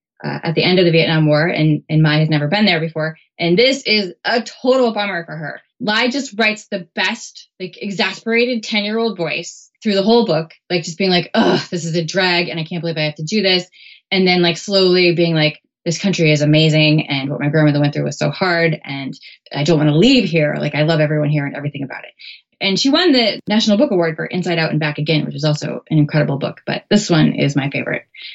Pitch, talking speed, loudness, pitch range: 170 Hz, 250 wpm, -16 LUFS, 155-200 Hz